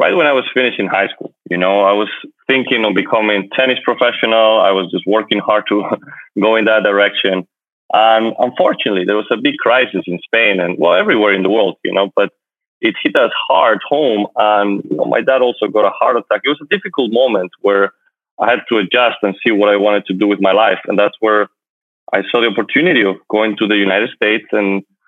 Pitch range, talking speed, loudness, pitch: 100-110 Hz, 225 wpm, -14 LUFS, 105 Hz